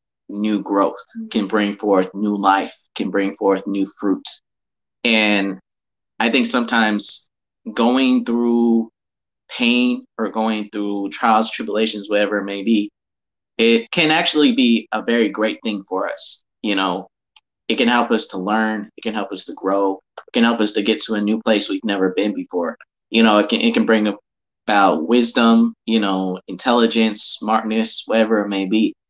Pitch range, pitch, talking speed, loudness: 100-115 Hz, 105 Hz, 170 wpm, -18 LUFS